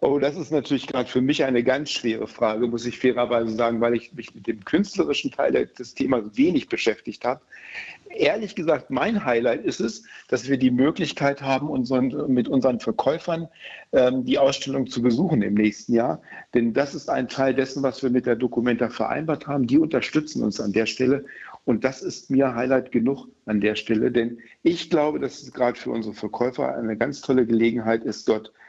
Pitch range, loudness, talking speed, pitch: 120-140 Hz, -23 LUFS, 195 wpm, 130 Hz